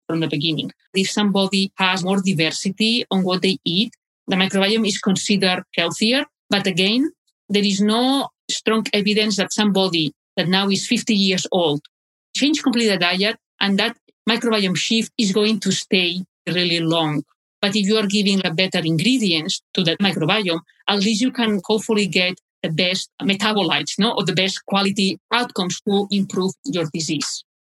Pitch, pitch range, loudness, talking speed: 195 Hz, 180-215 Hz, -19 LUFS, 165 wpm